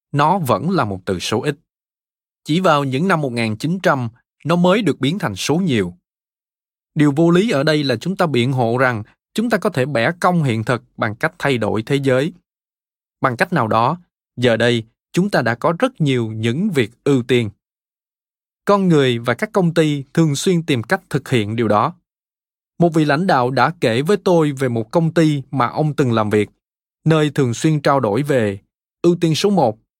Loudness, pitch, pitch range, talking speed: -17 LUFS, 140 Hz, 120-170 Hz, 200 wpm